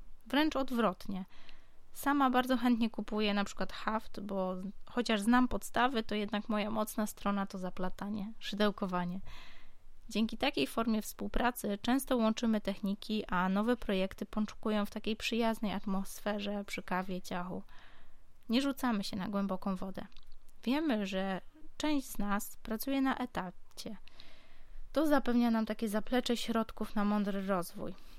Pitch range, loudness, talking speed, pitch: 200-240 Hz, -34 LUFS, 130 wpm, 215 Hz